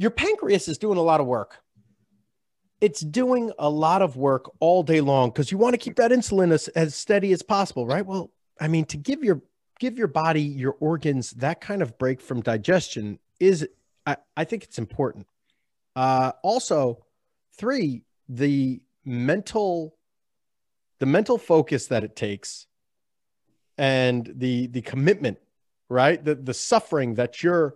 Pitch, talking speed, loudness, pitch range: 155 Hz, 160 wpm, -24 LUFS, 130-190 Hz